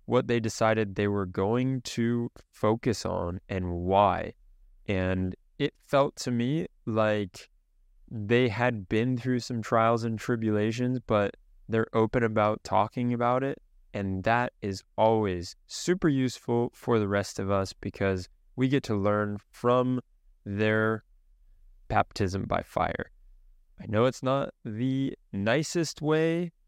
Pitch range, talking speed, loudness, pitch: 100-125 Hz, 135 wpm, -28 LUFS, 110 Hz